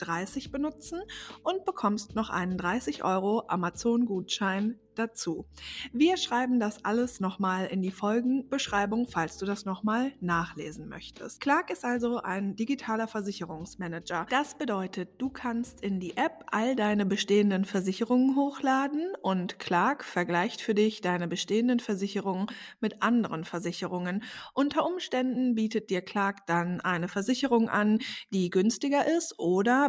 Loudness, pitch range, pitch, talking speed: -29 LUFS, 185-250 Hz, 210 Hz, 135 wpm